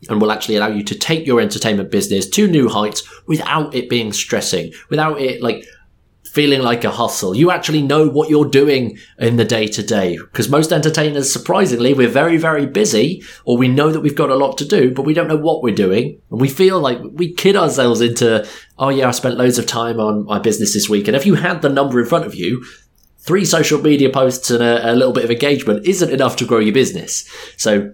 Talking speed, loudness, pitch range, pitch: 230 wpm, -15 LUFS, 115-155 Hz, 135 Hz